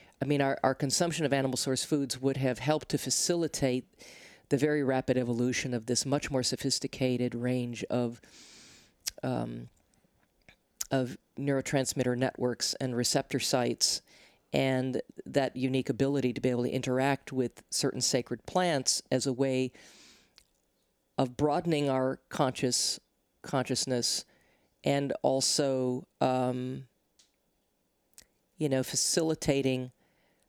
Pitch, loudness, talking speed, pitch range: 130 Hz, -30 LUFS, 115 wpm, 125-140 Hz